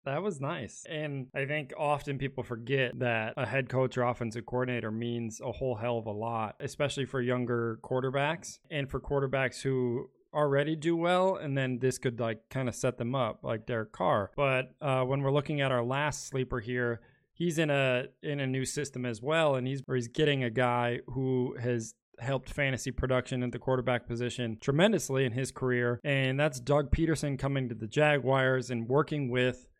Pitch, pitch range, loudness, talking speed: 130 Hz, 125-140 Hz, -31 LUFS, 195 wpm